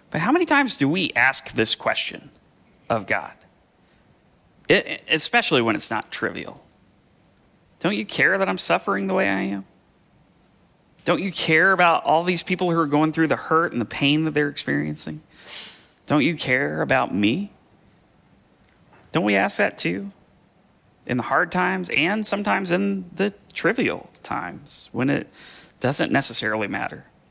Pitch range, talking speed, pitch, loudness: 120-185 Hz, 155 wpm, 160 Hz, -21 LUFS